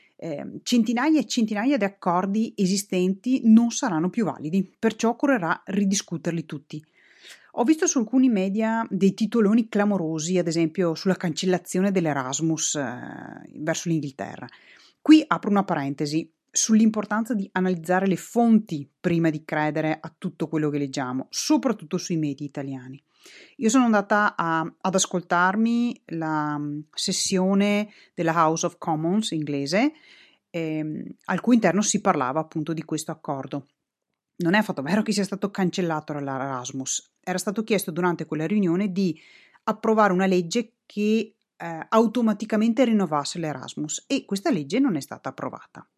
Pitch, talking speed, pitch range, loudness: 185 Hz, 140 wpm, 160-220 Hz, -24 LUFS